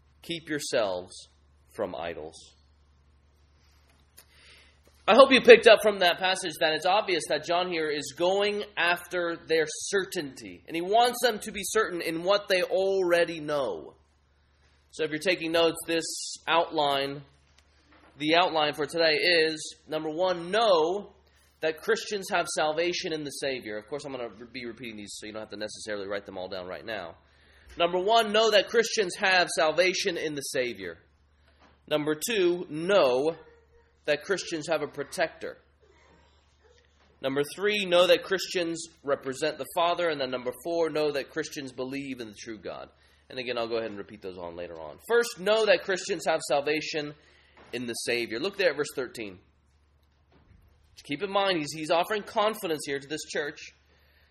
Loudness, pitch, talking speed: -27 LUFS, 150 Hz, 165 wpm